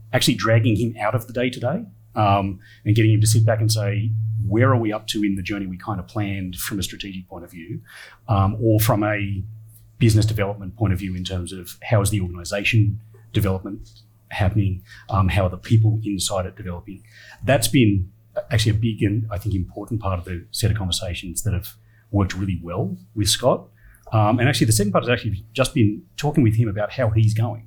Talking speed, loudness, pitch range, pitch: 215 wpm, -21 LUFS, 100-115 Hz, 110 Hz